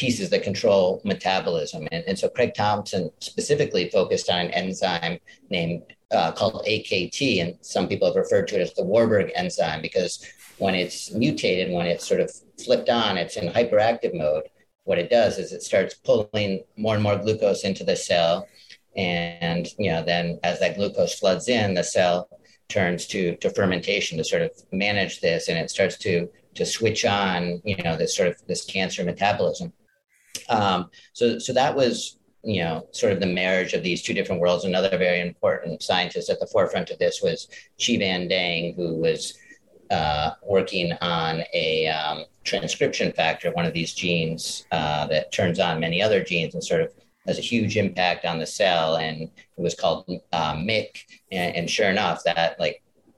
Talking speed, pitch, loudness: 185 wpm, 105 Hz, -24 LUFS